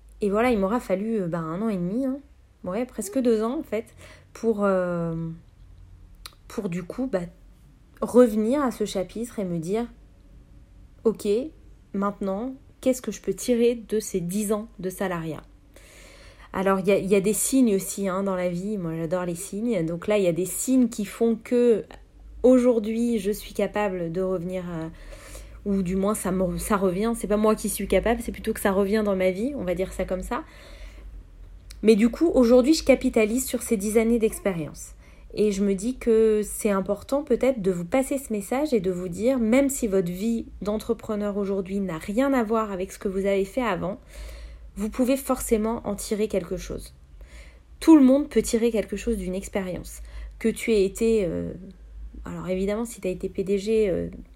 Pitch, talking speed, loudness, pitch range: 205 Hz, 195 wpm, -24 LUFS, 185-230 Hz